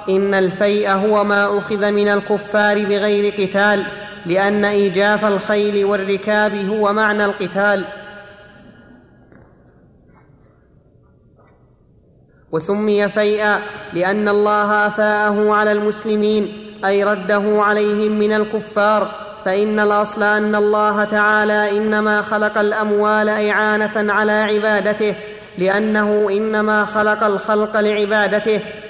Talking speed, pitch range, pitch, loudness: 90 wpm, 205-210 Hz, 210 Hz, -16 LUFS